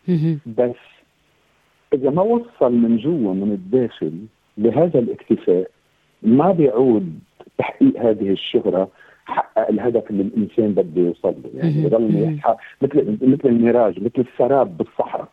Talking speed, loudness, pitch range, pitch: 115 wpm, -19 LUFS, 110-160 Hz, 120 Hz